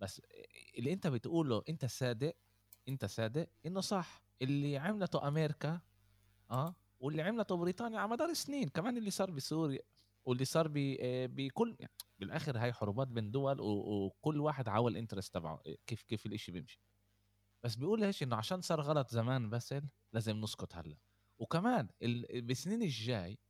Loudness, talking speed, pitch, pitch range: -39 LUFS, 145 wpm, 130 Hz, 105-160 Hz